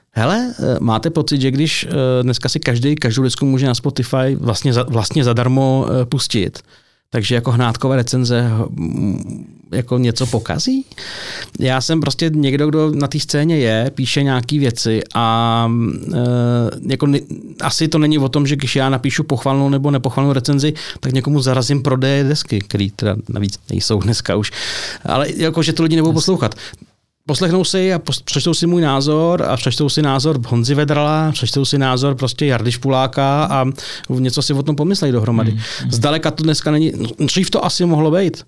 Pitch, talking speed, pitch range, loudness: 135 Hz, 165 wpm, 125-150 Hz, -16 LUFS